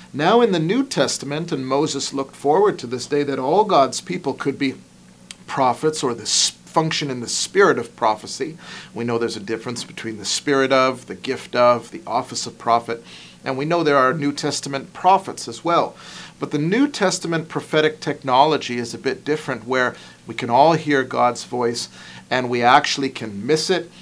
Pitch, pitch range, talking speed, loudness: 135 Hz, 120-155 Hz, 190 wpm, -20 LUFS